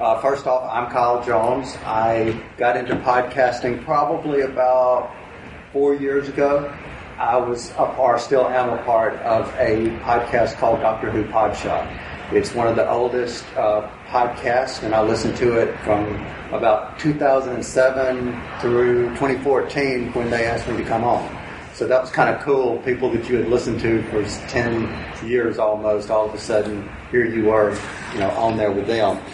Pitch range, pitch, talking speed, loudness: 110-125 Hz, 120 Hz, 170 wpm, -20 LUFS